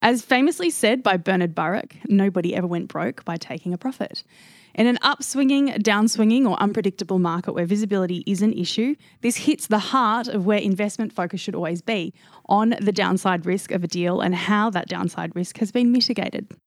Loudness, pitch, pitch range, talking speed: -22 LUFS, 205 Hz, 185-235 Hz, 185 wpm